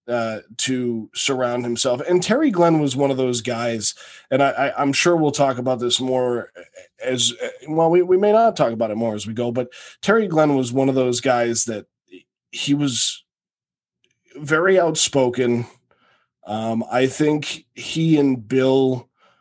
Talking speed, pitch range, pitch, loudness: 165 wpm, 120-150 Hz, 130 Hz, -19 LUFS